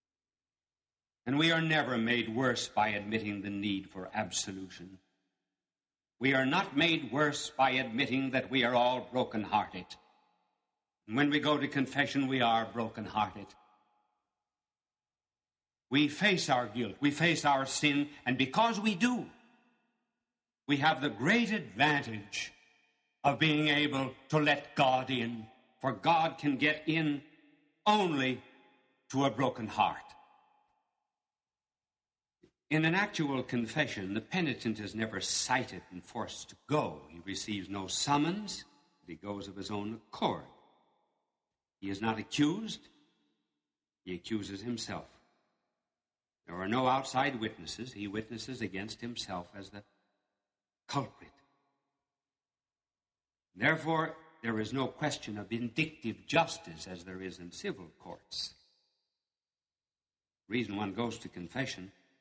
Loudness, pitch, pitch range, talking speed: -32 LUFS, 125 Hz, 105-145 Hz, 125 wpm